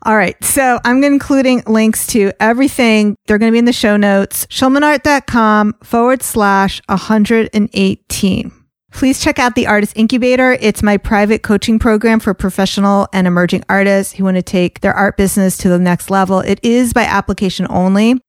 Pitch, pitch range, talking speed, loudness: 210 Hz, 195-240 Hz, 170 wpm, -12 LUFS